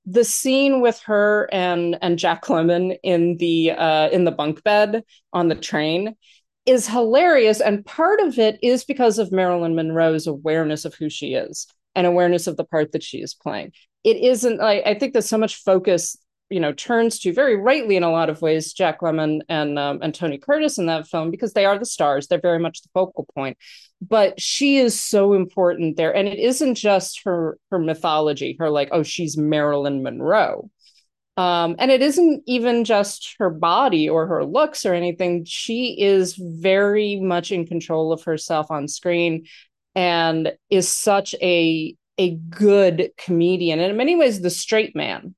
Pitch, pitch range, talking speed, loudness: 180 Hz, 165-215 Hz, 190 wpm, -19 LUFS